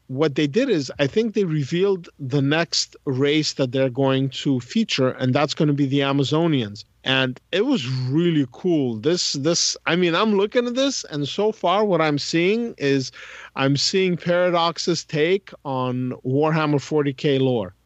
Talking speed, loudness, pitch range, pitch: 170 wpm, -21 LUFS, 135-175 Hz, 150 Hz